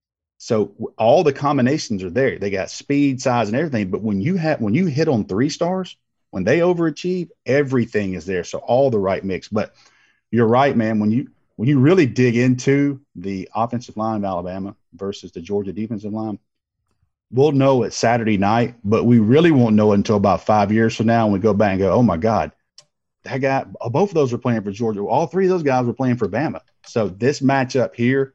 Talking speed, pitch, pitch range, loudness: 215 wpm, 115 Hz, 105-135 Hz, -19 LUFS